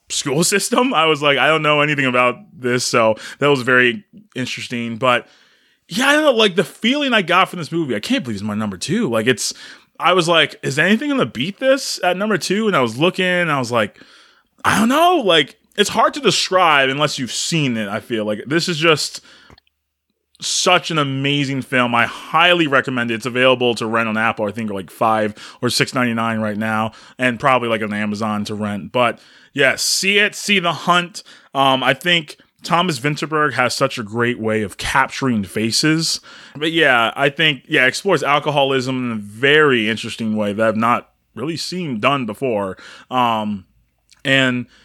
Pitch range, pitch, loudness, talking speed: 115-175 Hz, 135 Hz, -17 LUFS, 200 wpm